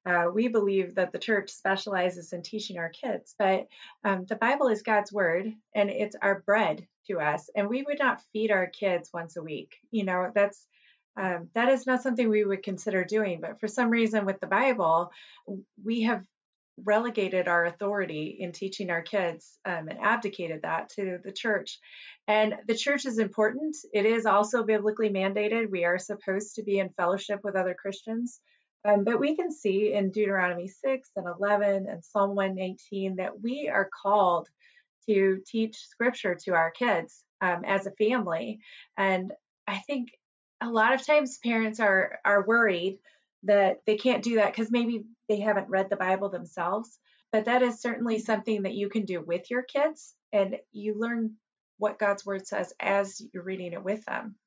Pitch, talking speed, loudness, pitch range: 205 Hz, 180 wpm, -28 LUFS, 190-225 Hz